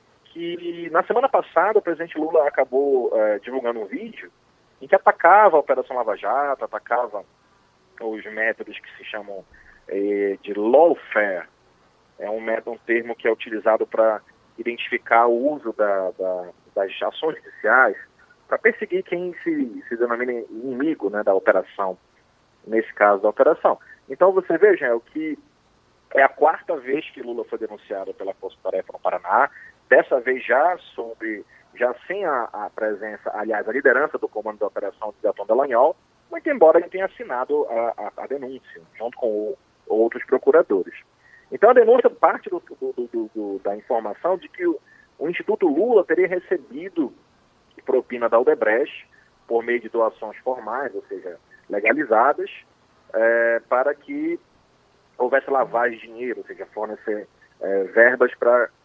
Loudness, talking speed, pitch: -21 LUFS, 155 wpm, 175 Hz